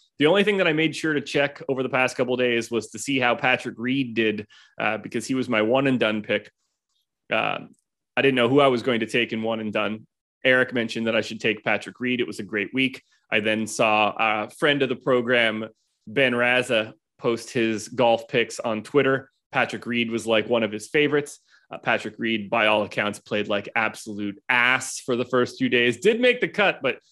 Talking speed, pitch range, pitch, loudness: 225 wpm, 110-130 Hz, 120 Hz, -23 LUFS